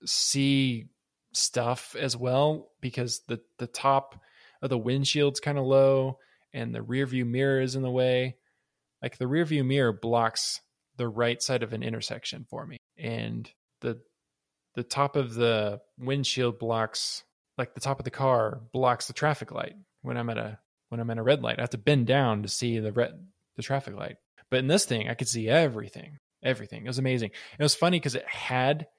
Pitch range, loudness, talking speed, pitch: 115-135 Hz, -28 LUFS, 195 wpm, 130 Hz